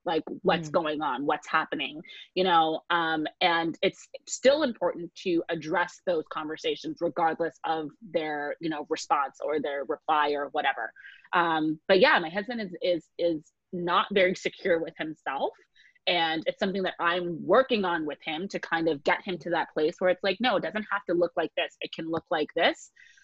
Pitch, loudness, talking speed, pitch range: 170 Hz, -28 LUFS, 190 wpm, 160-190 Hz